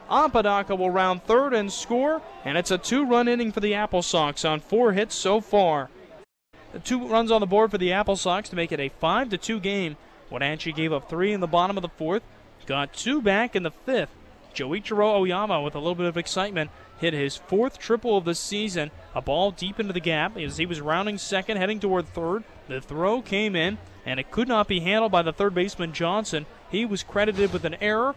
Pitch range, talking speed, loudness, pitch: 170-215 Hz, 220 wpm, -25 LUFS, 190 Hz